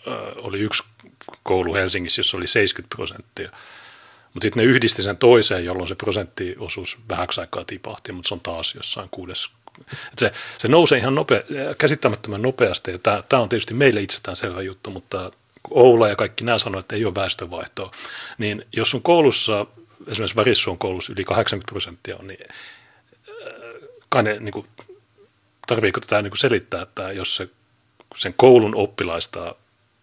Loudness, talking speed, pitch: -19 LUFS, 155 wpm, 155 Hz